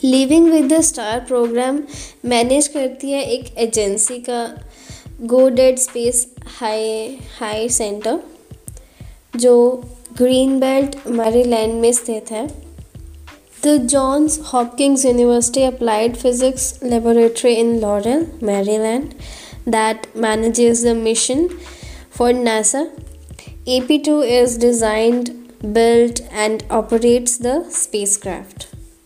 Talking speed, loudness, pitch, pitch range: 105 wpm, -16 LUFS, 240 Hz, 225-260 Hz